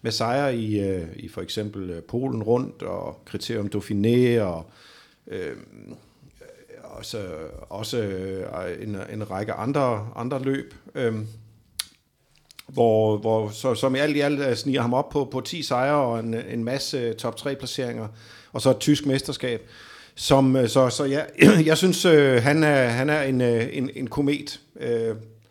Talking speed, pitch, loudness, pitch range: 155 wpm, 120 Hz, -23 LUFS, 110-140 Hz